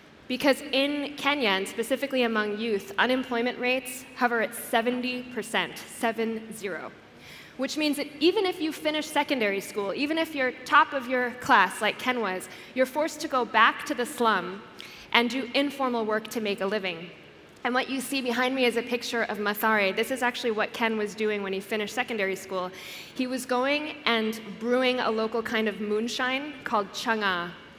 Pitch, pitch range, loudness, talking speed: 240 Hz, 215-260 Hz, -27 LUFS, 180 wpm